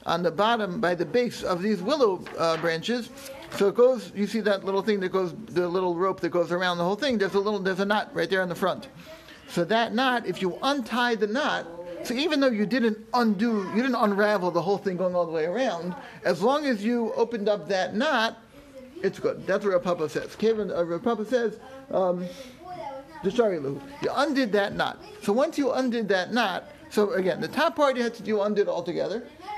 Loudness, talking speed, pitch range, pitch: -26 LUFS, 215 wpm, 185-245 Hz, 210 Hz